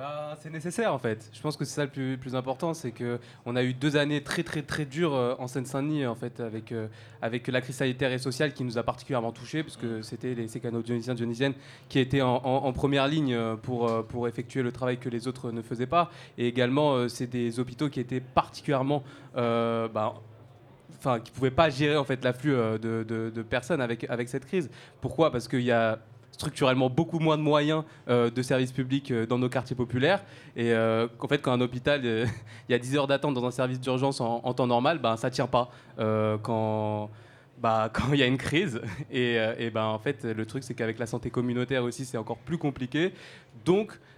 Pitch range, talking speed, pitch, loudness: 120-140 Hz, 225 wpm, 125 Hz, -29 LUFS